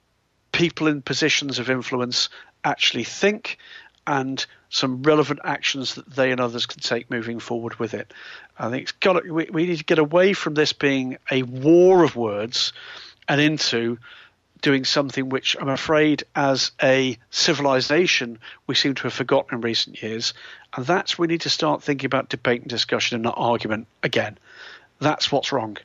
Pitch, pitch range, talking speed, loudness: 135 Hz, 120-150 Hz, 175 wpm, -21 LUFS